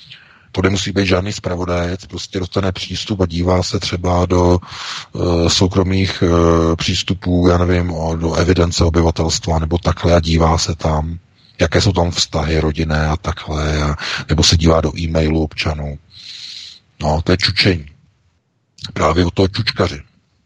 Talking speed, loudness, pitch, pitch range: 145 wpm, -16 LUFS, 90 Hz, 80-95 Hz